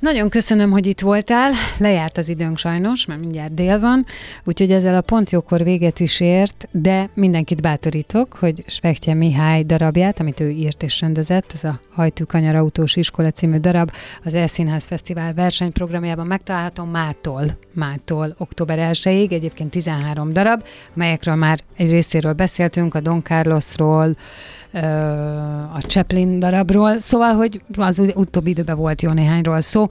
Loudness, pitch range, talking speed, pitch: -18 LUFS, 160-190 Hz, 150 wpm, 170 Hz